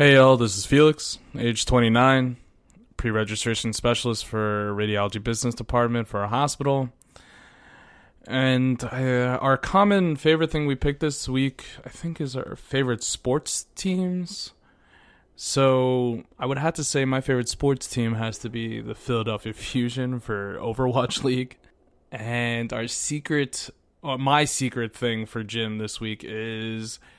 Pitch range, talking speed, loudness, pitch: 115-135 Hz, 140 wpm, -24 LUFS, 125 Hz